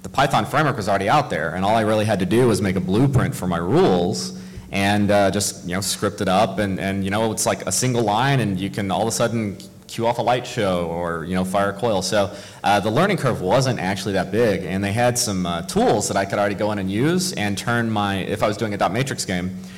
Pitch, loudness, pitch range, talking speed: 100 Hz, -20 LUFS, 95-110 Hz, 275 wpm